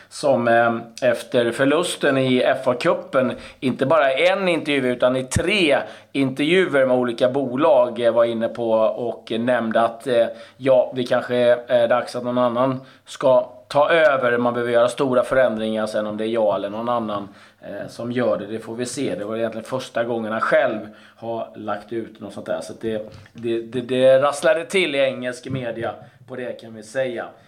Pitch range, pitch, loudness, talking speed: 110-130 Hz, 120 Hz, -20 LUFS, 185 wpm